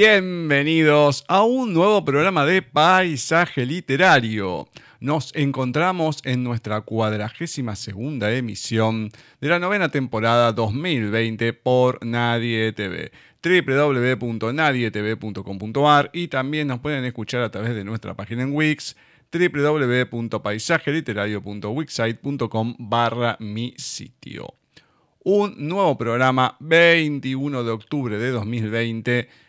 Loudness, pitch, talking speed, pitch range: -21 LUFS, 130 Hz, 100 wpm, 115-150 Hz